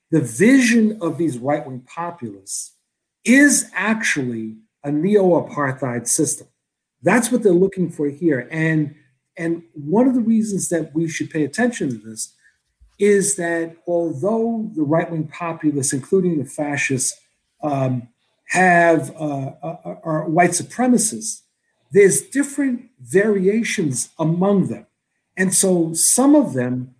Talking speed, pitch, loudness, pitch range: 120 wpm, 165 Hz, -18 LUFS, 145-200 Hz